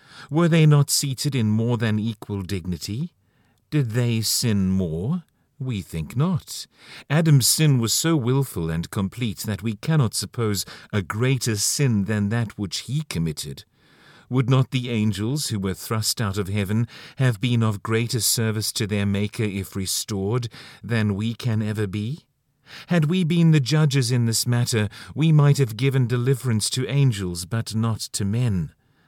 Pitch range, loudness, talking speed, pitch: 105-135 Hz, -22 LUFS, 165 wpm, 115 Hz